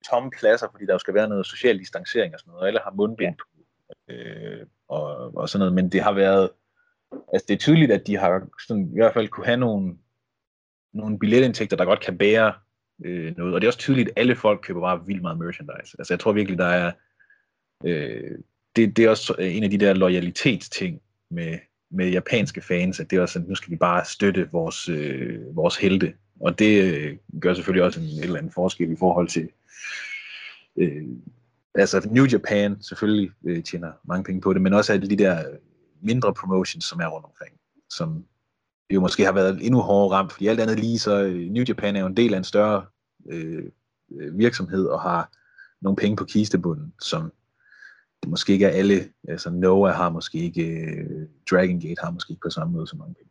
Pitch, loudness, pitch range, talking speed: 100 Hz, -22 LUFS, 90-110 Hz, 210 wpm